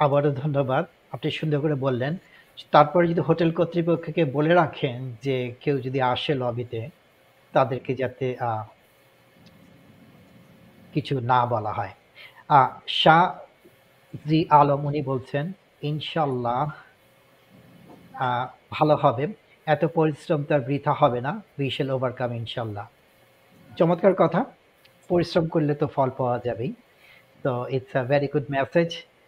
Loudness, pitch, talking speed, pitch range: -24 LUFS, 145 Hz, 110 wpm, 130-160 Hz